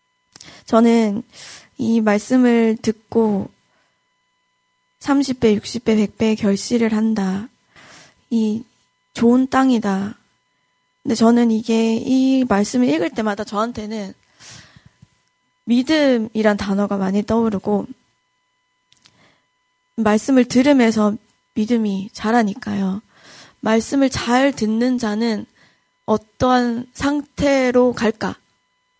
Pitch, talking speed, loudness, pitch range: 230 Hz, 175 characters per minute, -18 LUFS, 215-260 Hz